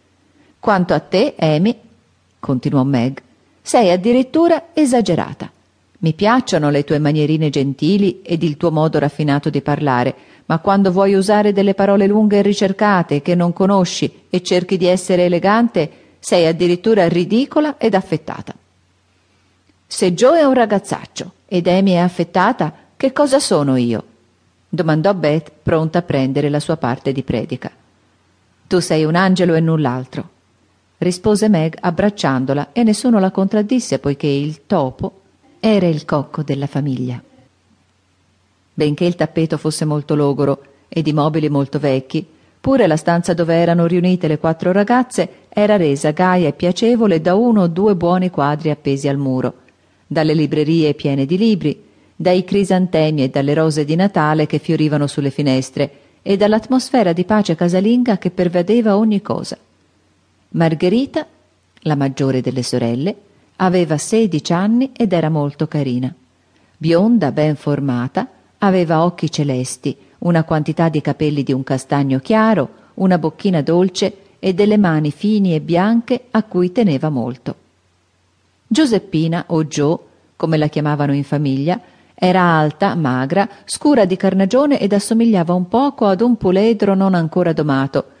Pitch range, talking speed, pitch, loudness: 140-195 Hz, 145 wpm, 165 Hz, -16 LUFS